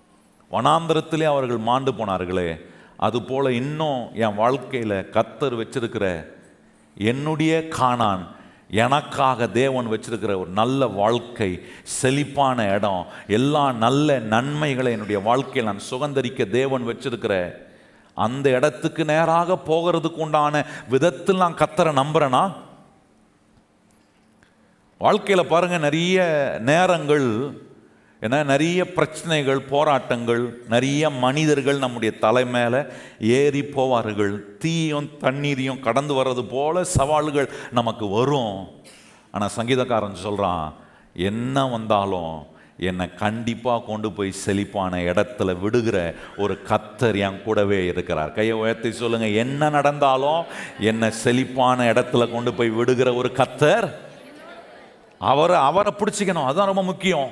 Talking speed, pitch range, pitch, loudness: 105 wpm, 110-145 Hz, 125 Hz, -21 LUFS